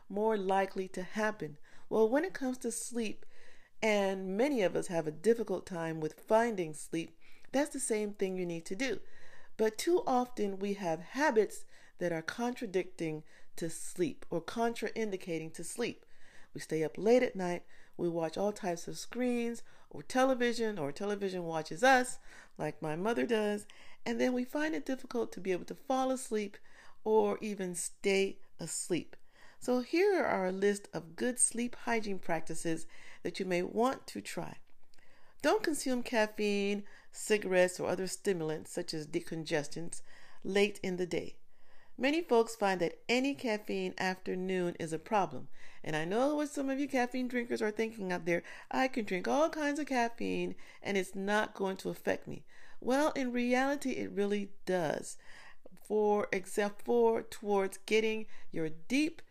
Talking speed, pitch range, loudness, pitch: 165 wpm, 180-245 Hz, -34 LUFS, 210 Hz